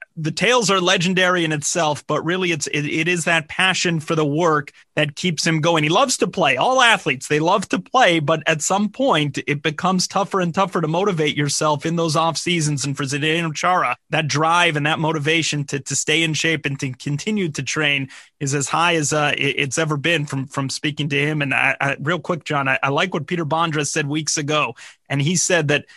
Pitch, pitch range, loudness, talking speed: 160 Hz, 145-175 Hz, -19 LUFS, 225 wpm